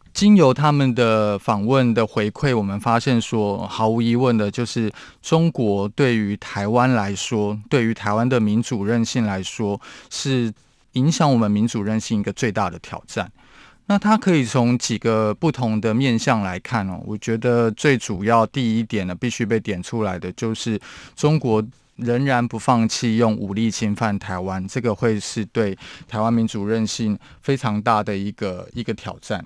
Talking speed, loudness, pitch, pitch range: 255 characters per minute, -20 LUFS, 115 Hz, 105-125 Hz